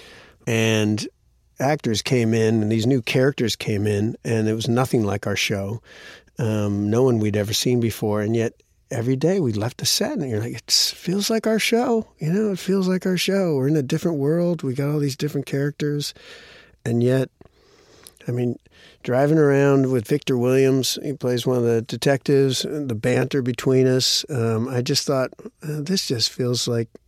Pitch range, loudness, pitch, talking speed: 115-150 Hz, -21 LUFS, 130 Hz, 190 wpm